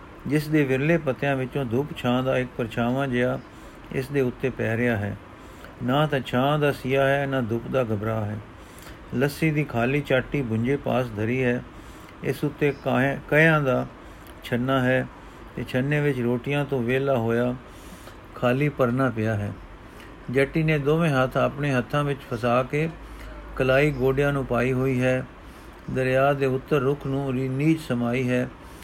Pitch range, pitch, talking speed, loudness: 120-140 Hz, 130 Hz, 155 wpm, -24 LUFS